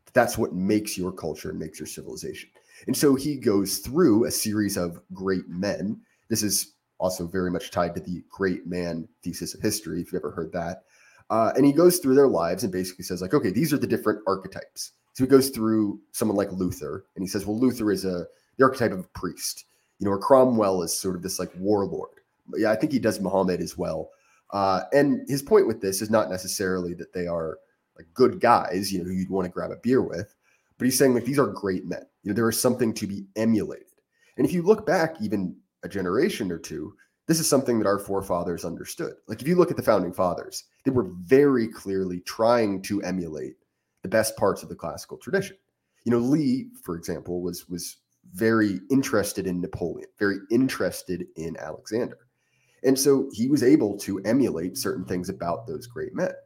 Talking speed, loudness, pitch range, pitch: 210 wpm, -25 LUFS, 90-130 Hz, 105 Hz